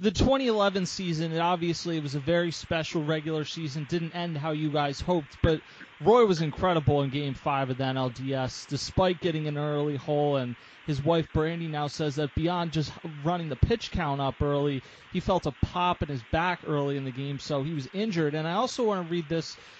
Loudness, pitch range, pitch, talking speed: -28 LUFS, 145-175 Hz, 155 Hz, 210 wpm